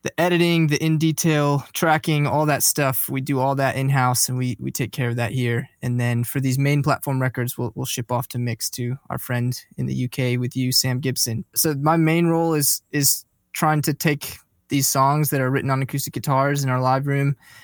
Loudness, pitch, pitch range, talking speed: -21 LUFS, 135 Hz, 125-145 Hz, 220 wpm